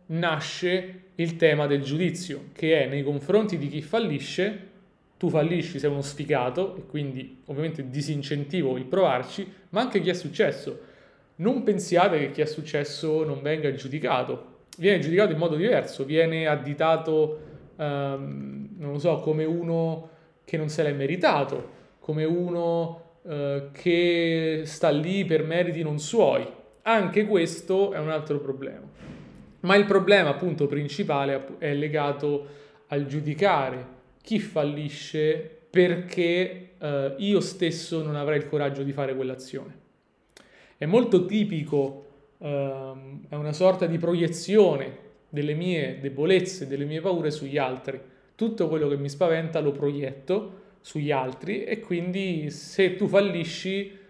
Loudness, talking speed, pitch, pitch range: -26 LUFS, 140 wpm, 155 Hz, 145-180 Hz